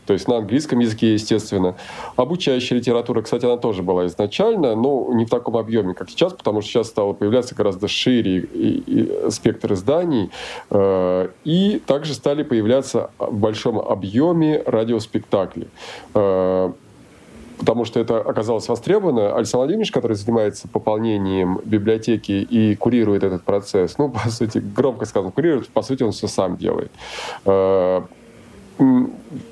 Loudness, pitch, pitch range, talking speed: -19 LUFS, 110 Hz, 100-125 Hz, 140 wpm